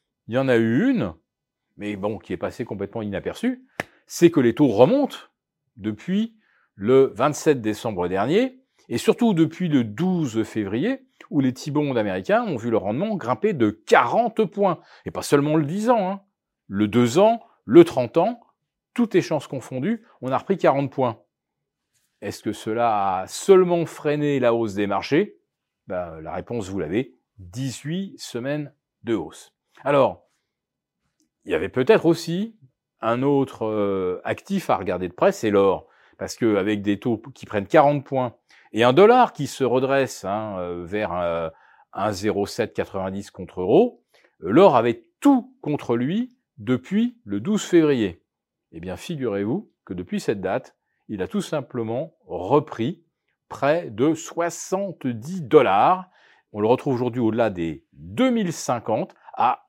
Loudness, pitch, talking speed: -22 LUFS, 140 Hz, 150 wpm